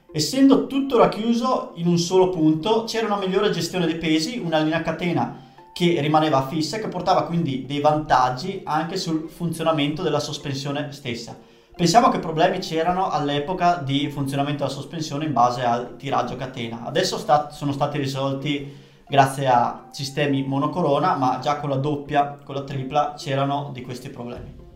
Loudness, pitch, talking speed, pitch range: -22 LUFS, 150 Hz, 160 wpm, 140-175 Hz